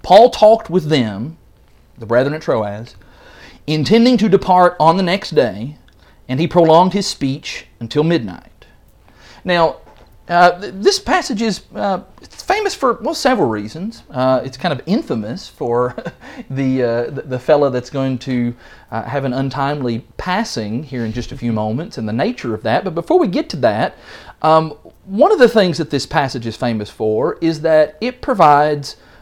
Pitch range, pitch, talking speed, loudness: 120-185 Hz, 145 Hz, 175 wpm, -16 LUFS